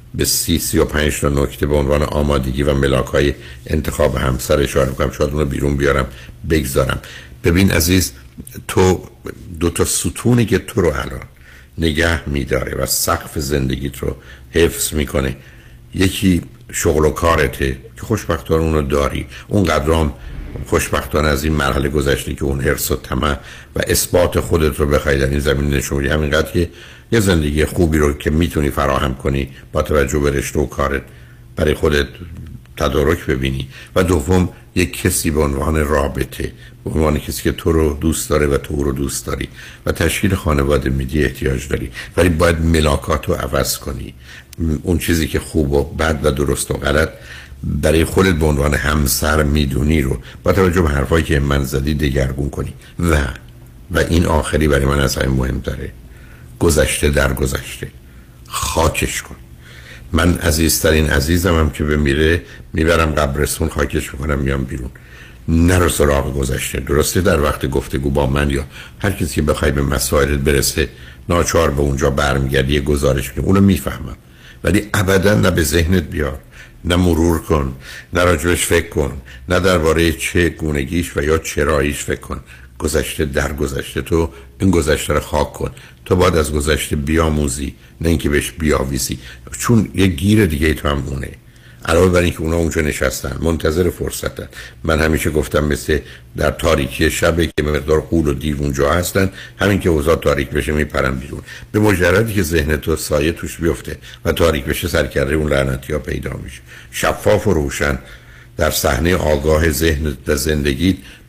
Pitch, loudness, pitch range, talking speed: 75 Hz, -17 LUFS, 70-80 Hz, 160 wpm